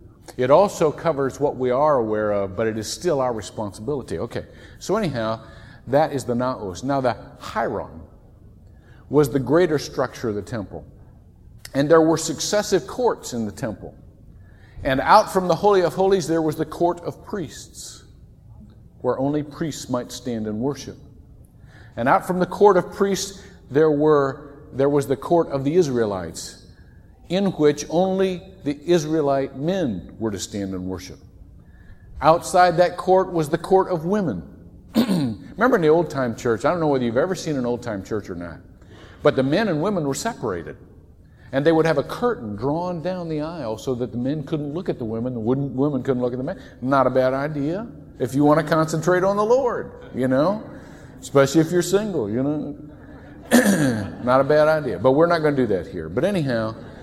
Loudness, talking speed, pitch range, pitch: -21 LUFS, 190 wpm, 115-165 Hz, 140 Hz